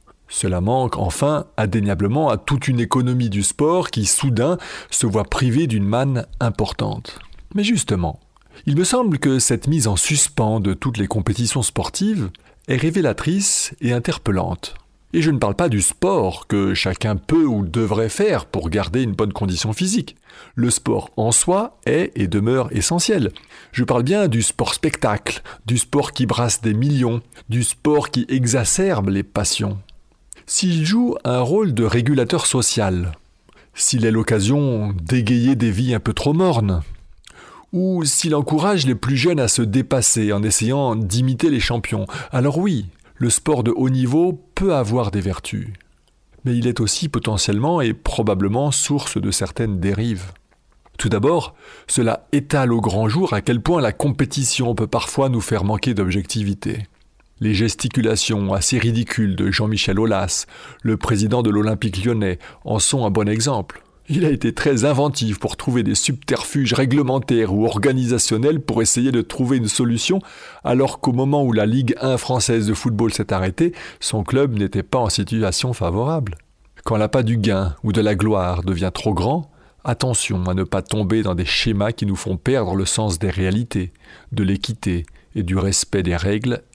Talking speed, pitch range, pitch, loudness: 165 wpm, 105-135 Hz, 115 Hz, -19 LUFS